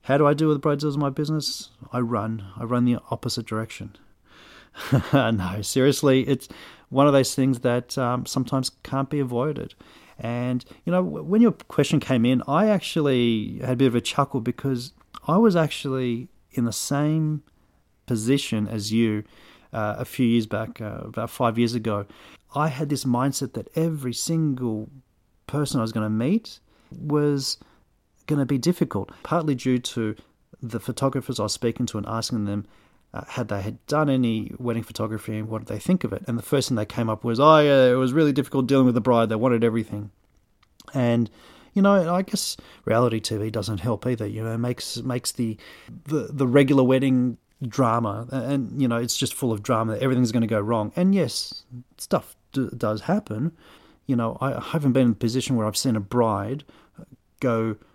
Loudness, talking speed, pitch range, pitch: -24 LUFS, 195 wpm, 115-140 Hz, 125 Hz